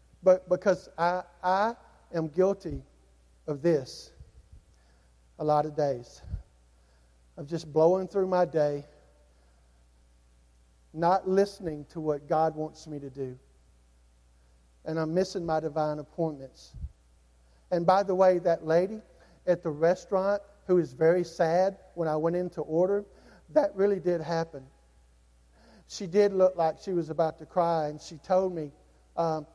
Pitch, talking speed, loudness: 160 Hz, 140 wpm, -28 LUFS